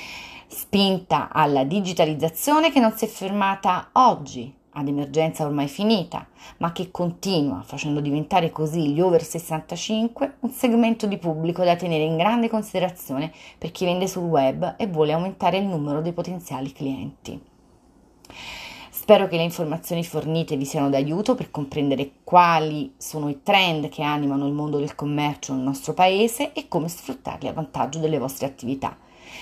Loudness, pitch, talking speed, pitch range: -23 LUFS, 165 Hz, 155 wpm, 145-190 Hz